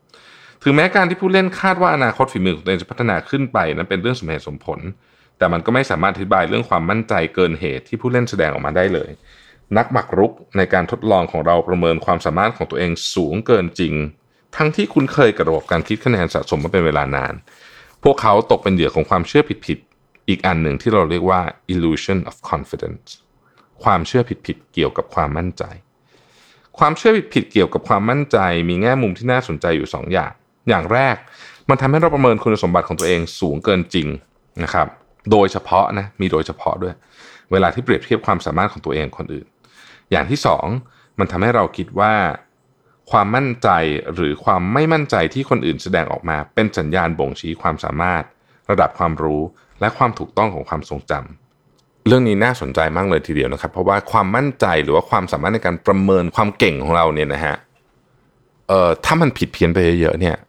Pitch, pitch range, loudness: 95 Hz, 85-125 Hz, -17 LUFS